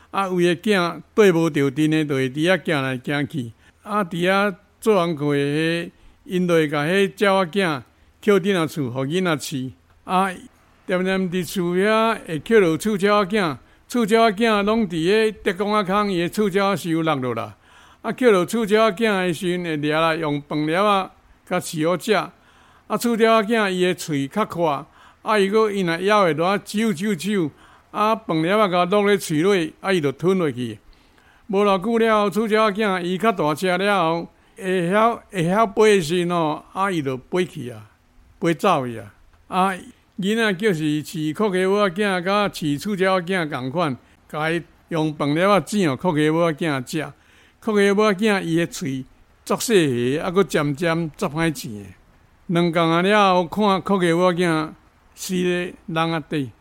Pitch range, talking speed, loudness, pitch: 155-205 Hz, 235 characters per minute, -20 LUFS, 180 Hz